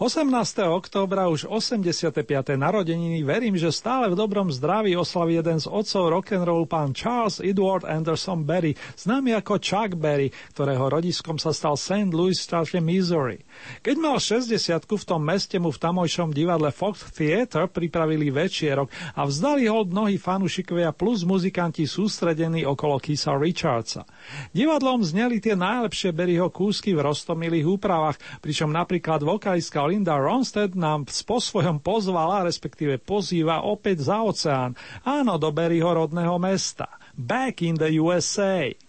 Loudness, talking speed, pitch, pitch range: -24 LUFS, 140 wpm, 175 Hz, 155-200 Hz